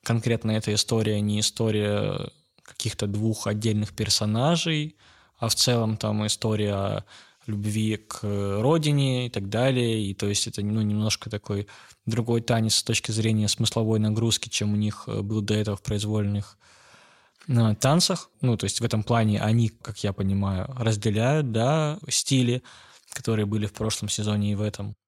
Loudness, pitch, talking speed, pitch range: -25 LUFS, 110 Hz, 155 wpm, 105-115 Hz